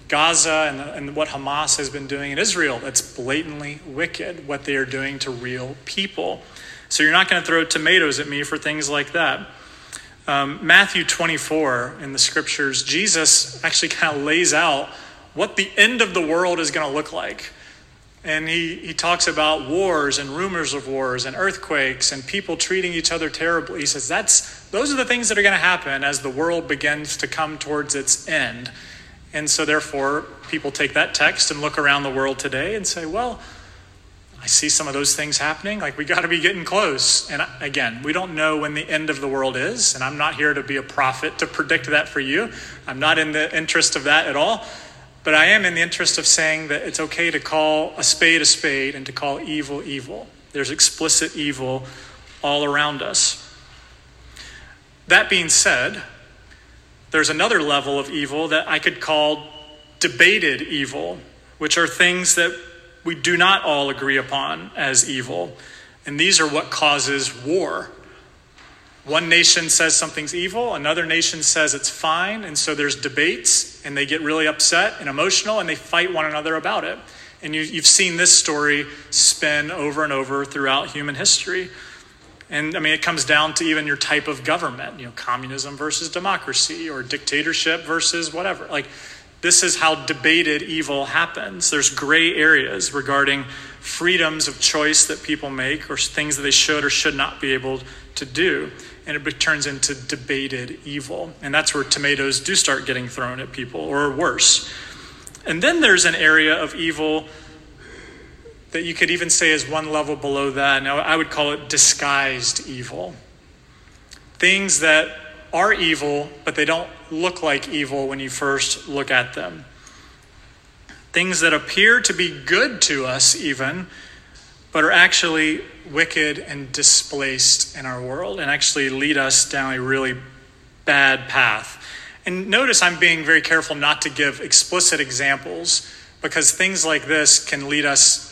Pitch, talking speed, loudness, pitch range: 150 Hz, 180 wpm, -18 LUFS, 140-160 Hz